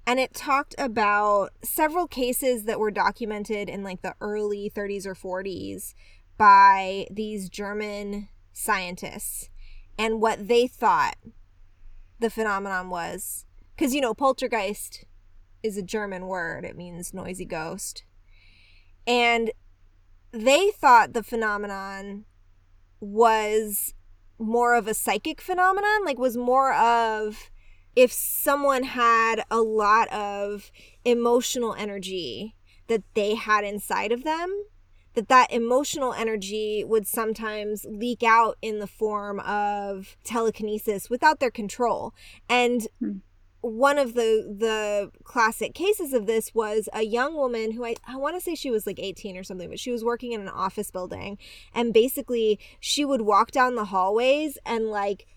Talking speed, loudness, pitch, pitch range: 140 wpm, -24 LUFS, 215 Hz, 195-240 Hz